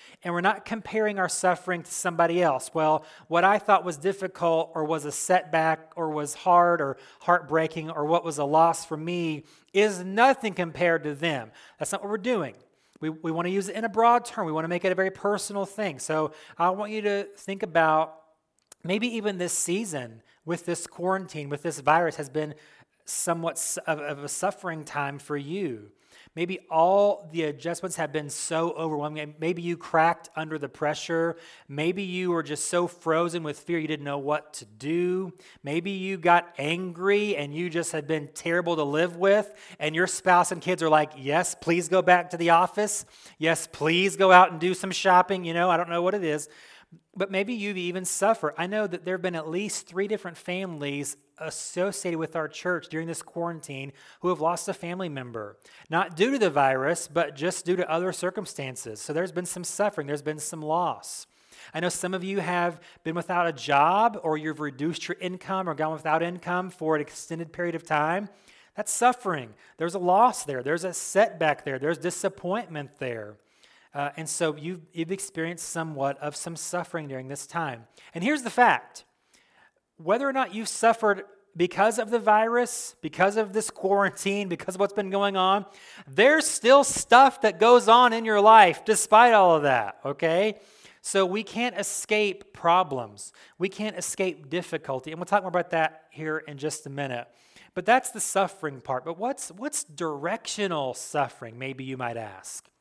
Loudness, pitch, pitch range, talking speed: -25 LUFS, 170 Hz, 155-195 Hz, 190 wpm